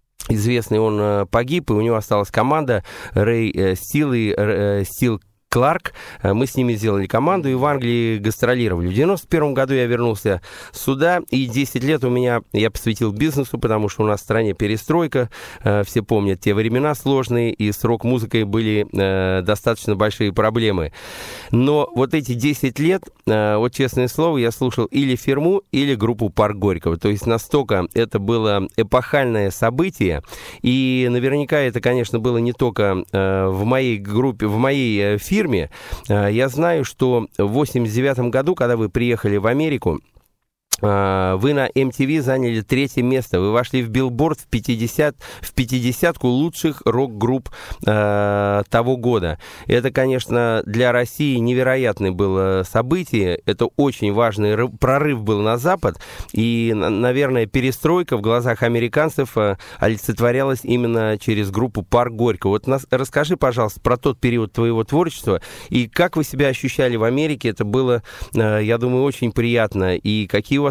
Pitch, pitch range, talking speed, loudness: 120 Hz, 105-135 Hz, 150 wpm, -19 LUFS